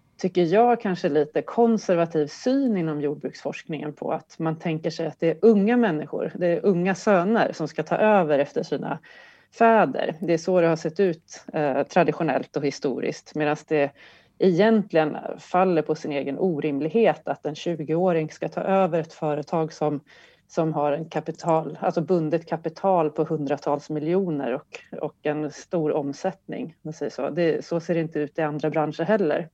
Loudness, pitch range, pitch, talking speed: -24 LUFS, 150-185 Hz, 165 Hz, 165 wpm